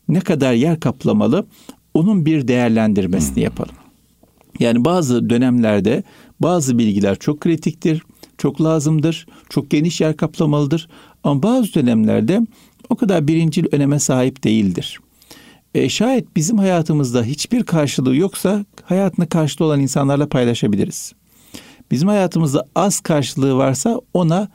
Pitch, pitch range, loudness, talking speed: 160 Hz, 135-180 Hz, -17 LUFS, 115 wpm